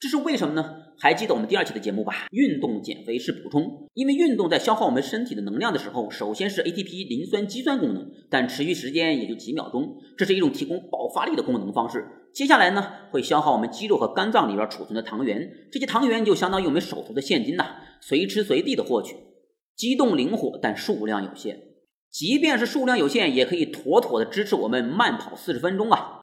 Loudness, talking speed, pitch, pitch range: -24 LUFS, 355 characters per minute, 270 Hz, 215-290 Hz